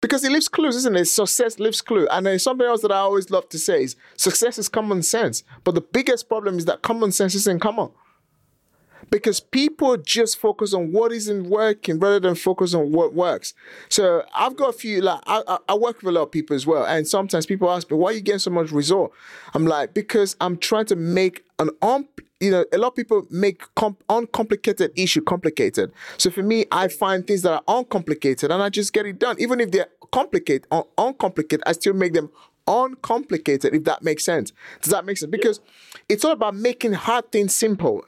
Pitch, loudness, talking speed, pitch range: 205 Hz, -21 LUFS, 215 wpm, 180-235 Hz